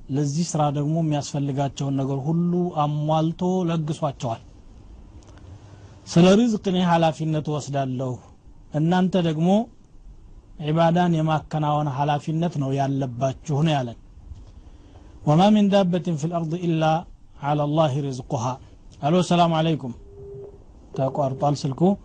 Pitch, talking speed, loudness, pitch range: 150 Hz, 110 wpm, -22 LUFS, 130-165 Hz